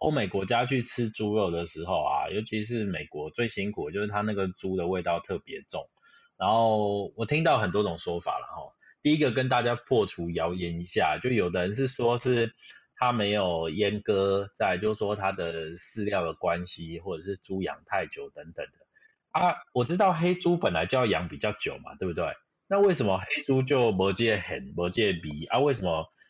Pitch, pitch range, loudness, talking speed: 105 Hz, 95-125 Hz, -28 LUFS, 285 characters per minute